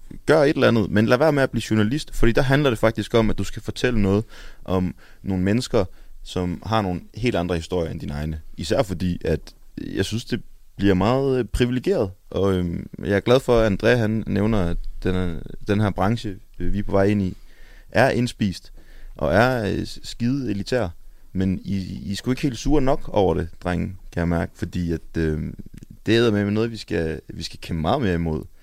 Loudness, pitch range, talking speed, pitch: -22 LUFS, 90-115 Hz, 200 wpm, 100 Hz